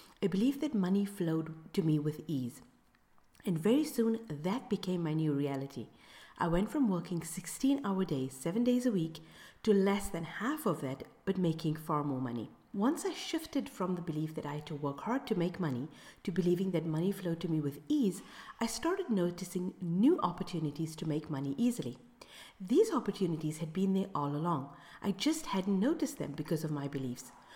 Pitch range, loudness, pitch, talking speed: 155-215 Hz, -34 LUFS, 180 Hz, 190 wpm